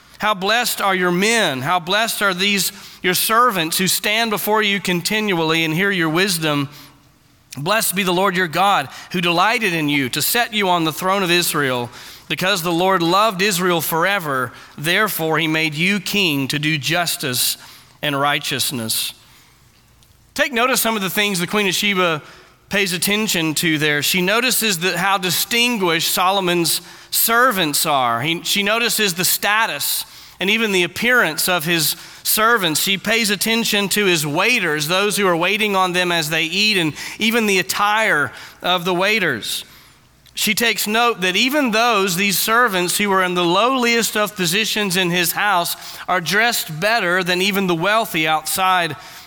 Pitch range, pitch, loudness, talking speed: 165-210 Hz, 185 Hz, -17 LUFS, 165 wpm